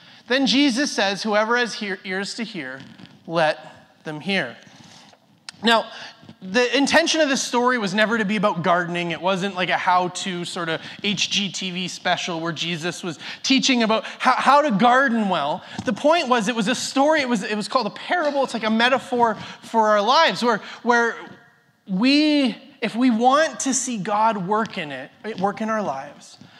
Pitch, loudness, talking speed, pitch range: 220 Hz, -20 LUFS, 180 wpm, 190-250 Hz